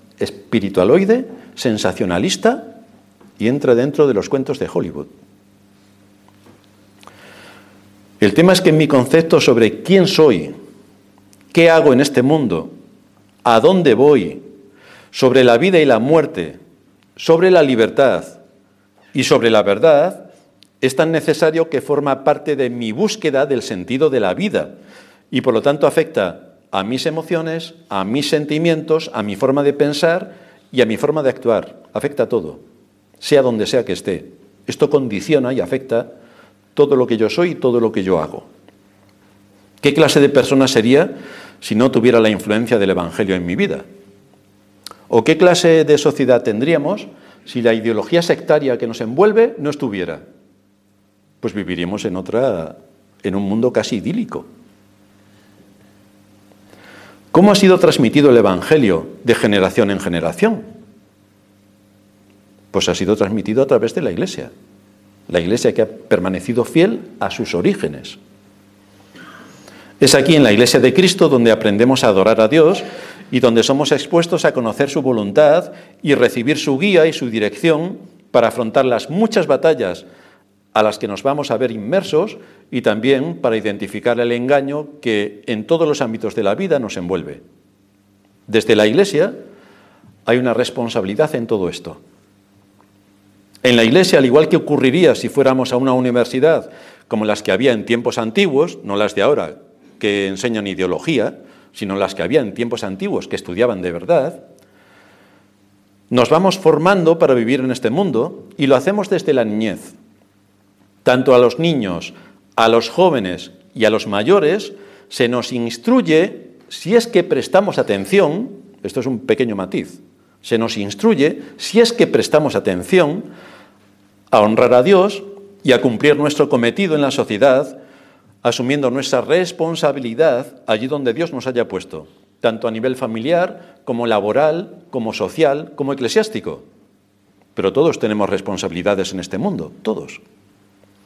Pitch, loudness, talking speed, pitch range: 120 Hz, -15 LUFS, 150 wpm, 100-155 Hz